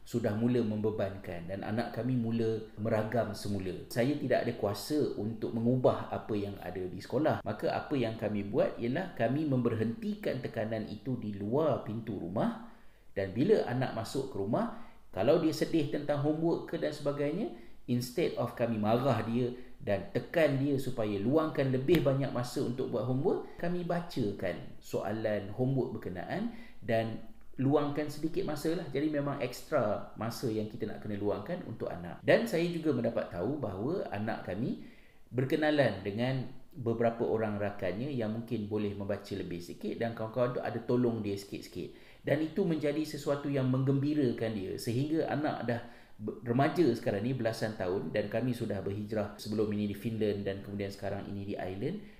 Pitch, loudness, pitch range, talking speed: 115 Hz, -33 LUFS, 105-140 Hz, 160 wpm